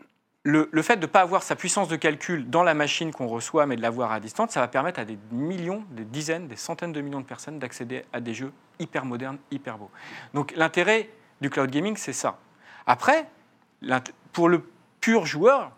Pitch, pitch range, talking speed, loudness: 150 Hz, 130-170 Hz, 210 wpm, -25 LUFS